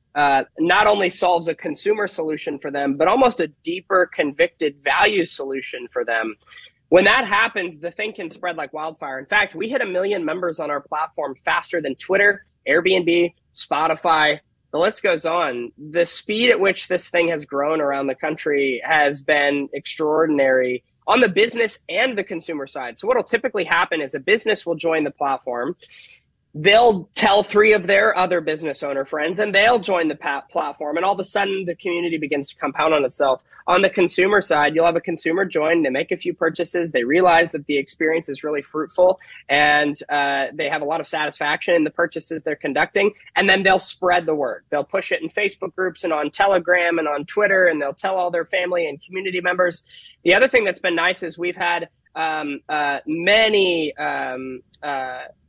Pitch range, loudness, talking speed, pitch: 150-190 Hz, -19 LUFS, 195 wpm, 170 Hz